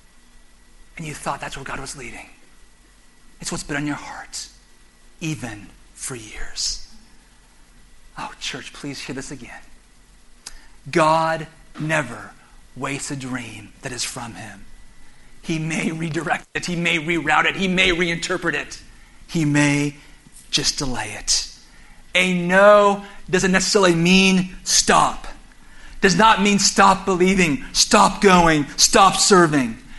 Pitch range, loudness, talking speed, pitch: 115-180 Hz, -18 LUFS, 130 wpm, 155 Hz